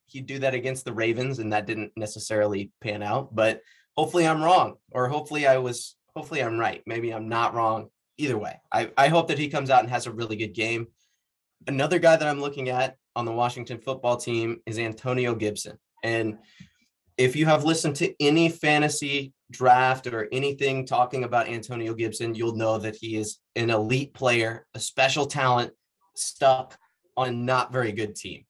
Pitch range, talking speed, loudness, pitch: 115-135 Hz, 185 wpm, -25 LUFS, 120 Hz